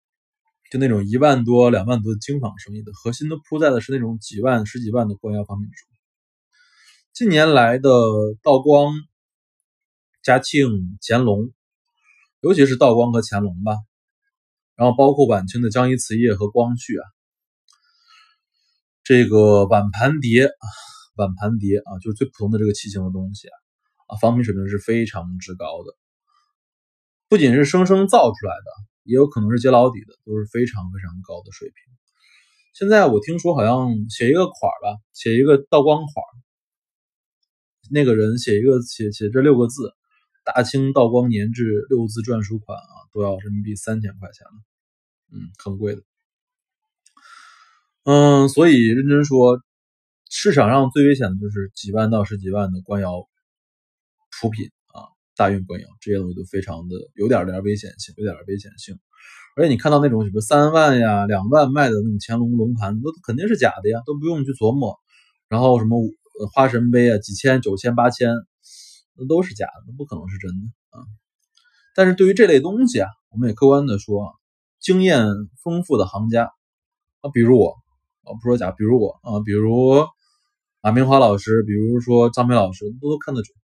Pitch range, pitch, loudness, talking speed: 105-145 Hz, 120 Hz, -18 LUFS, 255 characters per minute